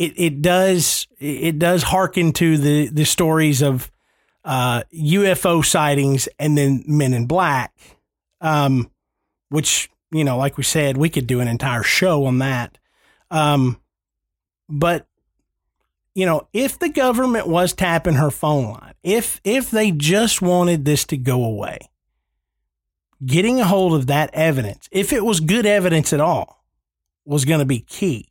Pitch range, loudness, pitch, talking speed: 130-175 Hz, -18 LUFS, 150 Hz, 155 wpm